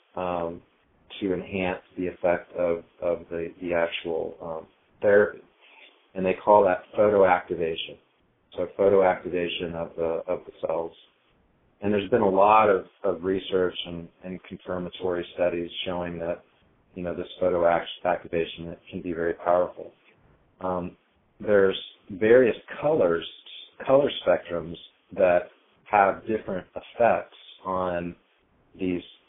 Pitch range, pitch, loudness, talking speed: 85-95 Hz, 90 Hz, -25 LUFS, 120 wpm